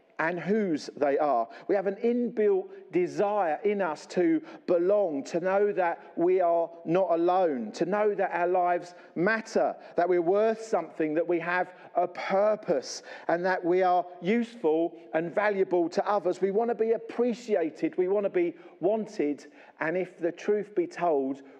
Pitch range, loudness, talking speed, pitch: 170-215 Hz, -28 LUFS, 165 wpm, 190 Hz